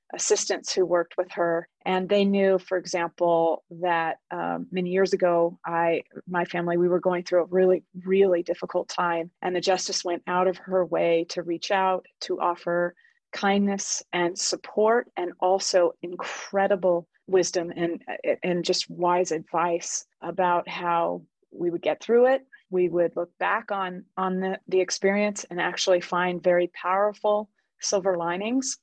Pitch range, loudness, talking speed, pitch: 175-195 Hz, -25 LUFS, 155 wpm, 180 Hz